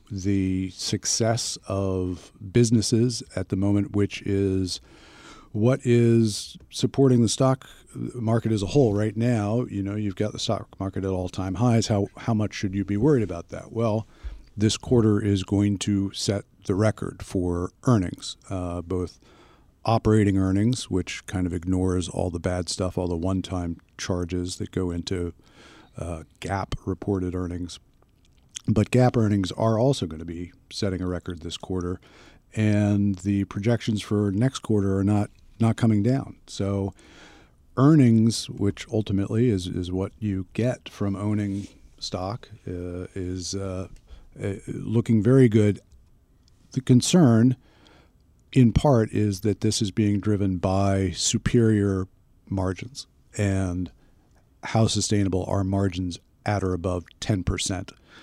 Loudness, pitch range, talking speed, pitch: -24 LUFS, 95-115 Hz, 145 wpm, 100 Hz